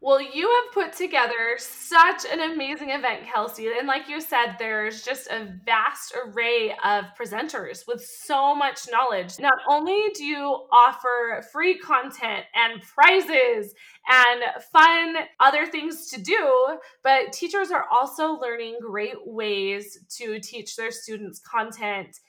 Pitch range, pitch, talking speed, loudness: 225-320 Hz, 255 Hz, 140 wpm, -22 LUFS